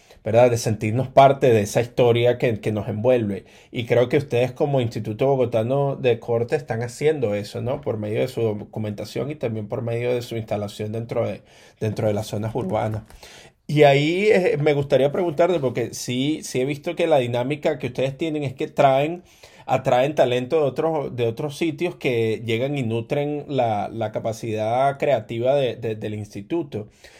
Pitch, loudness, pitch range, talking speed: 120 Hz, -22 LUFS, 110-145 Hz, 180 wpm